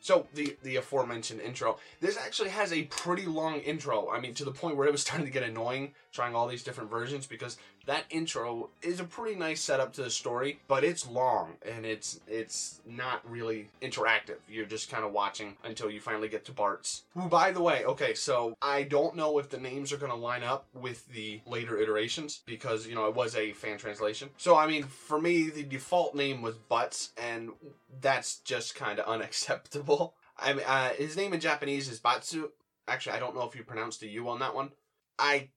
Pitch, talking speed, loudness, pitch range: 135 Hz, 215 wpm, -32 LUFS, 115-150 Hz